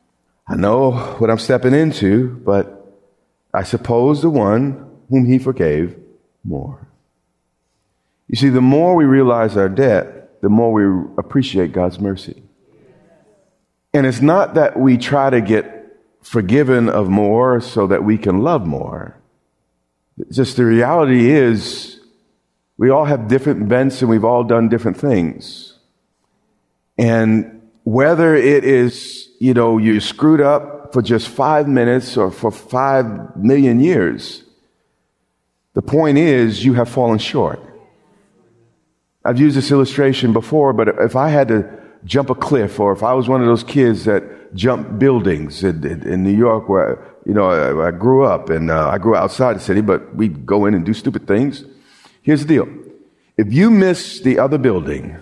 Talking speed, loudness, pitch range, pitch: 160 wpm, -15 LUFS, 100-135 Hz, 120 Hz